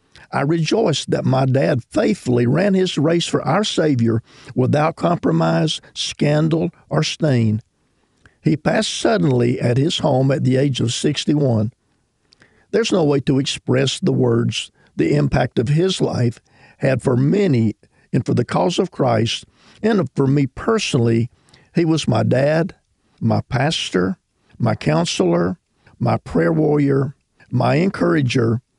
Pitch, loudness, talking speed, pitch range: 135 Hz, -18 LUFS, 140 wpm, 120-160 Hz